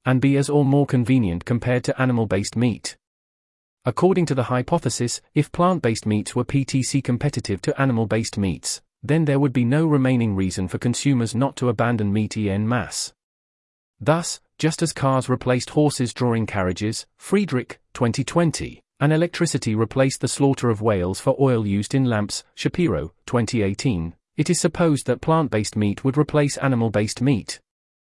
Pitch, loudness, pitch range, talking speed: 125 Hz, -22 LUFS, 110-140 Hz, 165 wpm